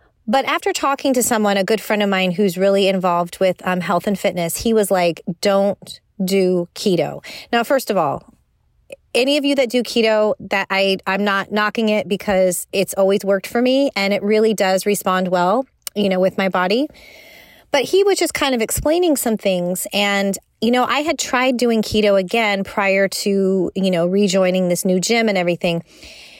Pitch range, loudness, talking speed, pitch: 190-230 Hz, -18 LUFS, 195 wpm, 200 Hz